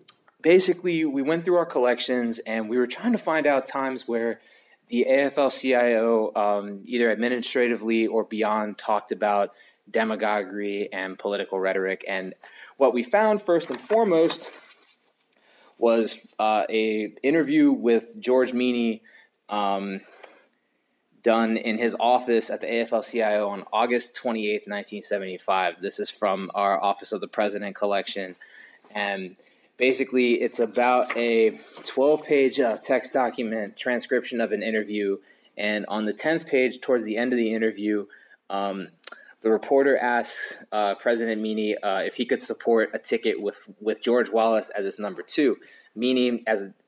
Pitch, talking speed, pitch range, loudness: 115 Hz, 145 wpm, 105-125 Hz, -24 LUFS